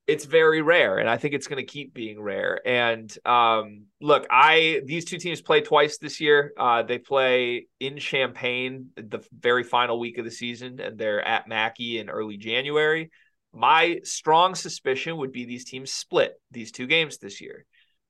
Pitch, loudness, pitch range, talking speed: 130 Hz, -23 LUFS, 120-155 Hz, 180 wpm